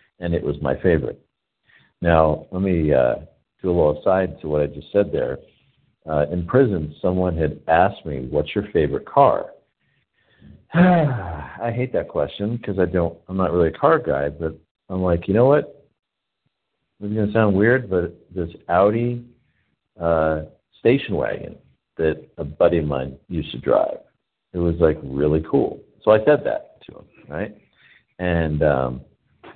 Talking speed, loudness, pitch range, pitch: 170 wpm, -21 LUFS, 75-105 Hz, 85 Hz